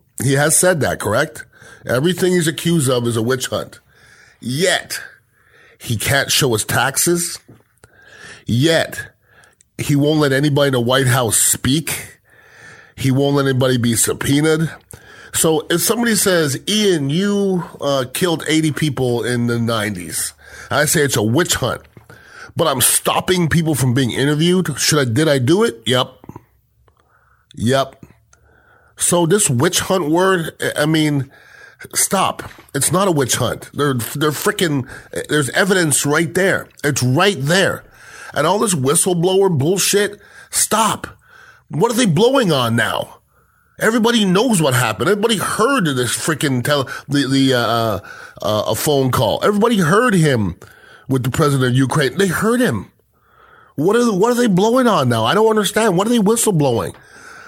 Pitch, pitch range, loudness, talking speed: 150 Hz, 130-185 Hz, -16 LUFS, 155 wpm